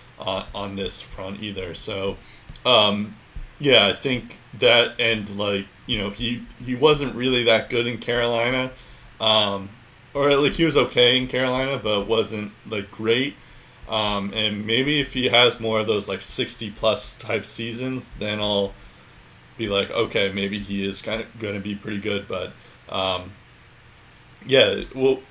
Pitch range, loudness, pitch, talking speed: 100-125 Hz, -22 LUFS, 110 Hz, 160 wpm